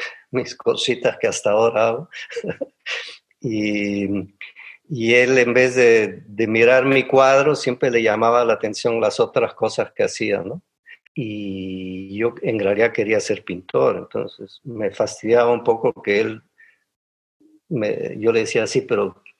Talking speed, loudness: 145 wpm, -19 LUFS